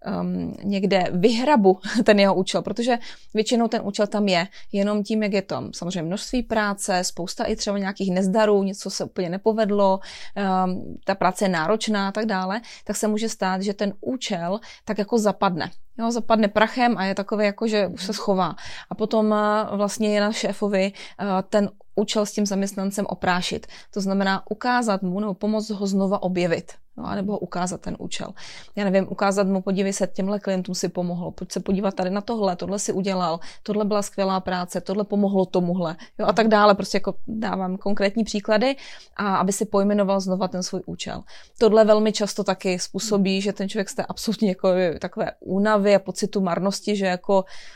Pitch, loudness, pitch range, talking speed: 200 Hz, -23 LUFS, 190-215 Hz, 185 wpm